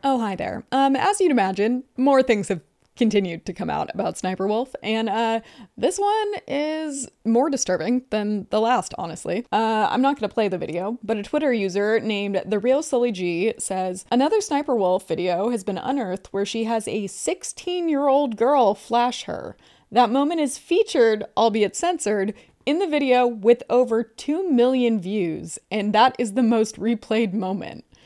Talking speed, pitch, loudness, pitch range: 175 wpm, 230 Hz, -22 LUFS, 205-270 Hz